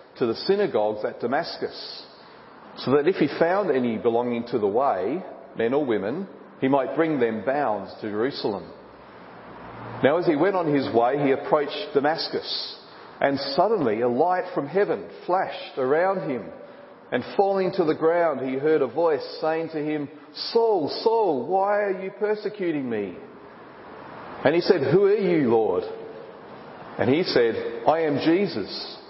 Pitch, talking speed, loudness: 180 Hz, 155 wpm, -24 LUFS